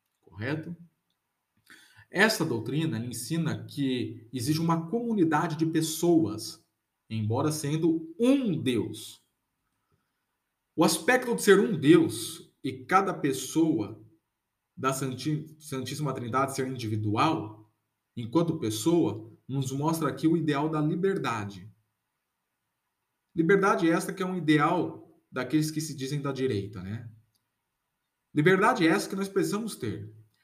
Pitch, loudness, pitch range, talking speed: 150 Hz, -27 LUFS, 115-165 Hz, 110 wpm